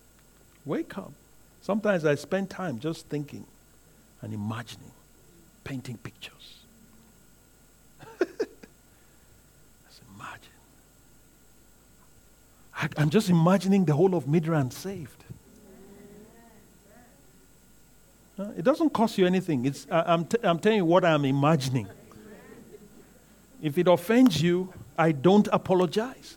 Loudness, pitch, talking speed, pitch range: -25 LUFS, 180 Hz, 100 wpm, 150-205 Hz